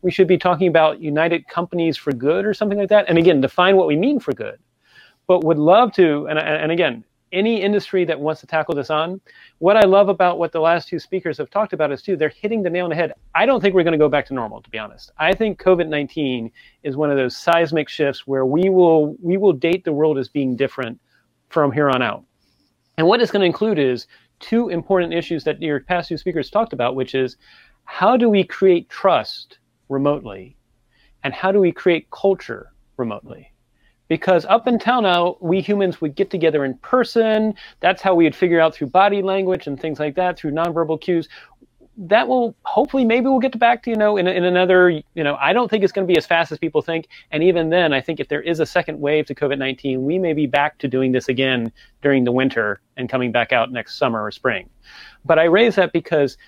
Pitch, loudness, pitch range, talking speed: 170 Hz, -18 LUFS, 145-190 Hz, 235 wpm